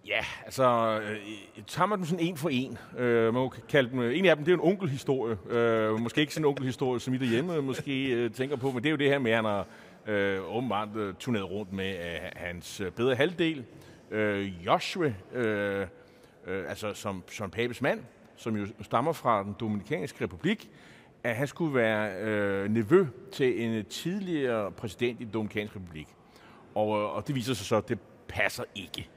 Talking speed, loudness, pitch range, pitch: 170 wpm, -30 LUFS, 105-135 Hz, 115 Hz